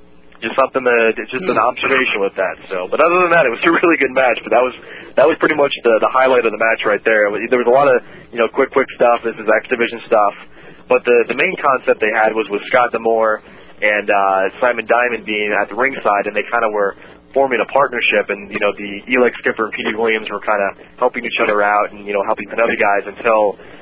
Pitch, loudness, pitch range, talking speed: 110 Hz, -15 LUFS, 100-120 Hz, 245 wpm